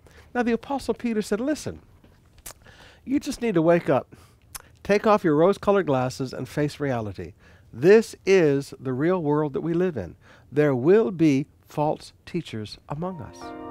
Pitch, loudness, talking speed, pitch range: 150 Hz, -23 LUFS, 160 wpm, 130-200 Hz